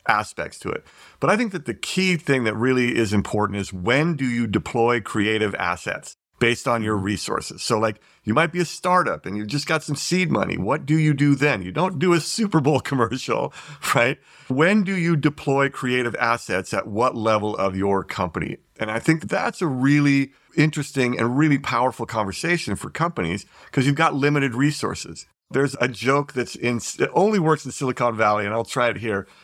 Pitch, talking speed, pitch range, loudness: 130 Hz, 200 wpm, 115-155 Hz, -22 LUFS